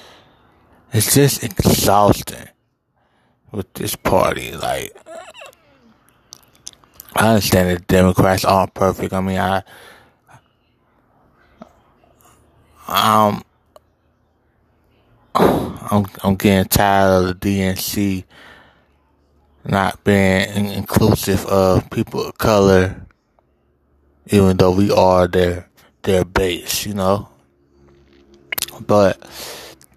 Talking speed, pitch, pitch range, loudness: 90 wpm, 95 Hz, 85-100 Hz, -16 LUFS